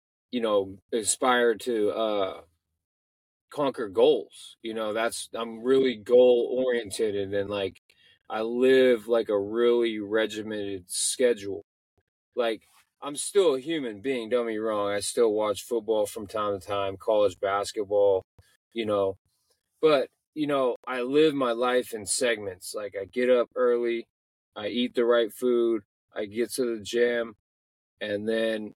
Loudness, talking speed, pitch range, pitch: -26 LUFS, 150 wpm, 100-125 Hz, 115 Hz